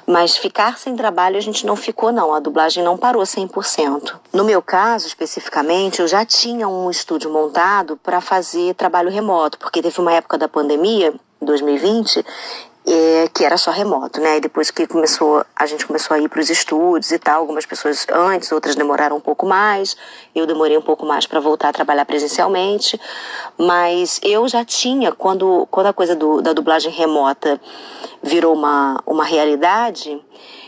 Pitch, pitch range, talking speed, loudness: 165 Hz, 155-190 Hz, 175 wpm, -16 LUFS